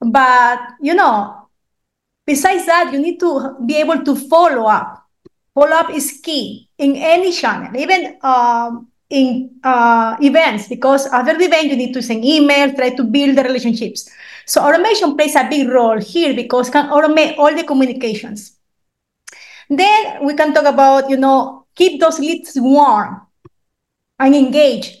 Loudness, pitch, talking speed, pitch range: -13 LUFS, 275 Hz, 160 wpm, 250-310 Hz